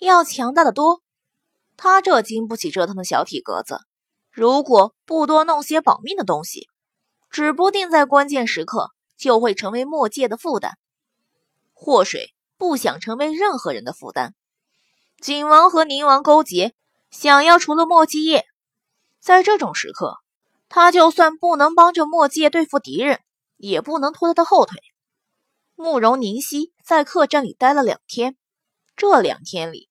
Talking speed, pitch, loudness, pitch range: 225 characters per minute, 300 Hz, -17 LUFS, 260-335 Hz